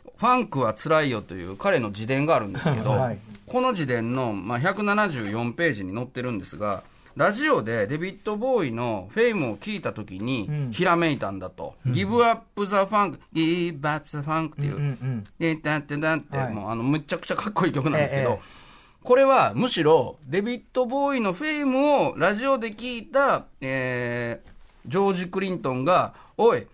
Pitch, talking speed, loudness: 155 Hz, 330 characters per minute, -24 LUFS